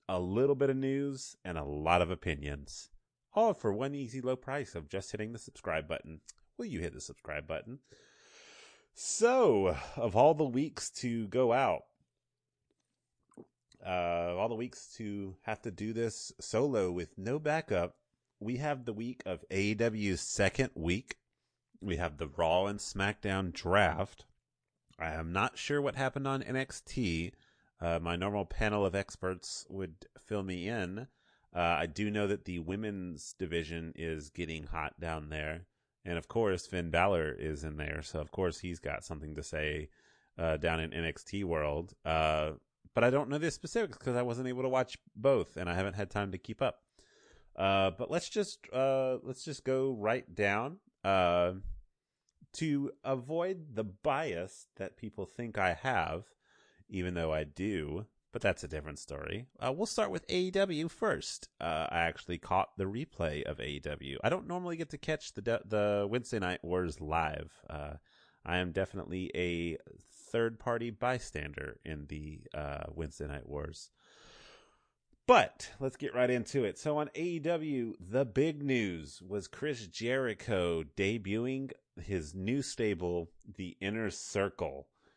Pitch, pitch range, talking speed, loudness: 100 Hz, 85-130 Hz, 165 wpm, -35 LUFS